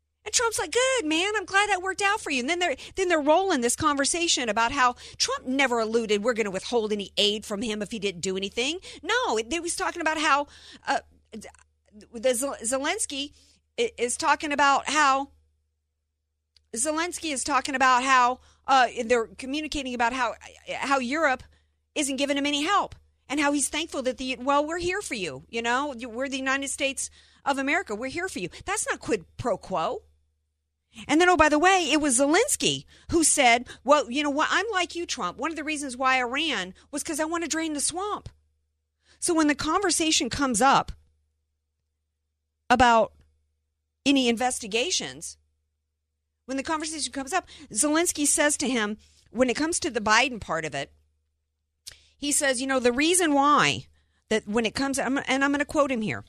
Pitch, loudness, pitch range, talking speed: 270 Hz, -25 LUFS, 210-310 Hz, 185 wpm